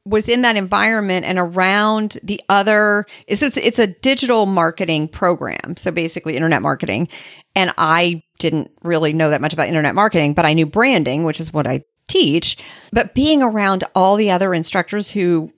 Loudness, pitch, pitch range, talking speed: -16 LUFS, 185 Hz, 160-210 Hz, 175 wpm